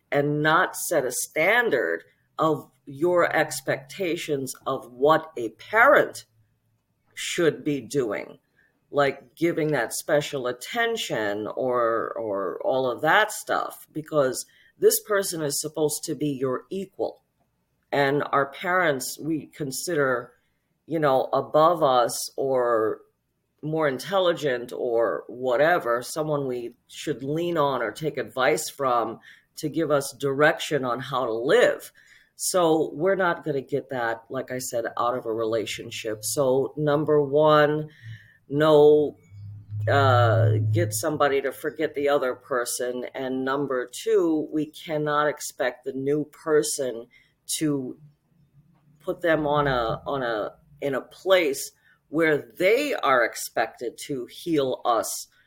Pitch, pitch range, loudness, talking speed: 145 Hz, 125-155 Hz, -24 LUFS, 125 wpm